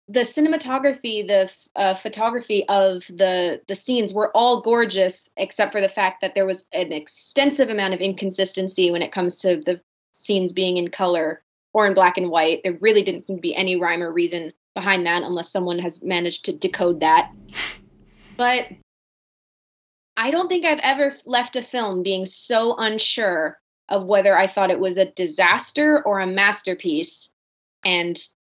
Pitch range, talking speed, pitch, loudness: 180-225 Hz, 170 wpm, 195 Hz, -20 LUFS